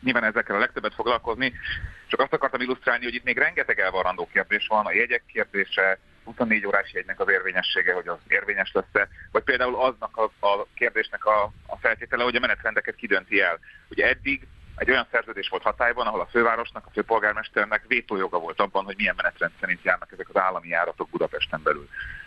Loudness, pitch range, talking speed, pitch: -24 LUFS, 100-130 Hz, 180 wpm, 110 Hz